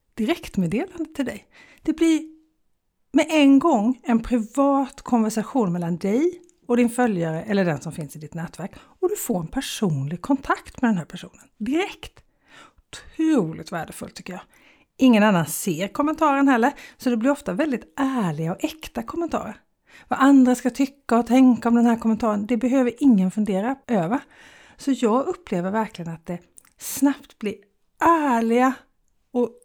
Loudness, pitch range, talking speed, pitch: -22 LUFS, 205-280 Hz, 155 wpm, 245 Hz